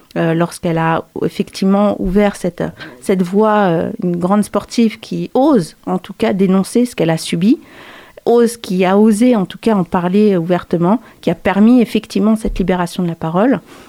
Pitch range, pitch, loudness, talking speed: 180-220 Hz, 200 Hz, -15 LUFS, 175 wpm